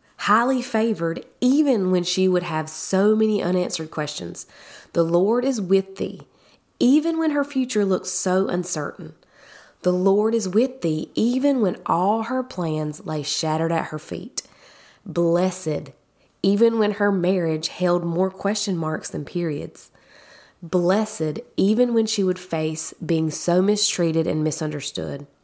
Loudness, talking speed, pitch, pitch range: -22 LUFS, 140 wpm, 185 Hz, 160-215 Hz